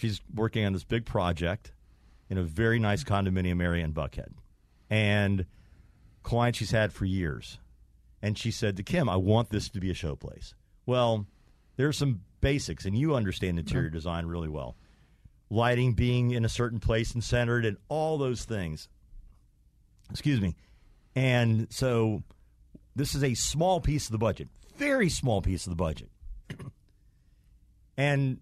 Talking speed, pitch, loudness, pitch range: 160 wpm, 105 Hz, -29 LUFS, 90-120 Hz